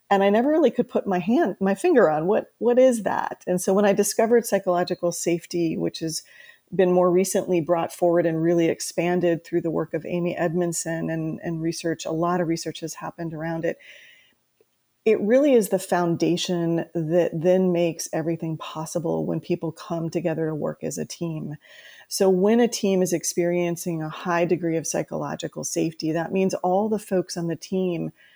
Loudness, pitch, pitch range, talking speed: -23 LUFS, 175 Hz, 165-190 Hz, 185 wpm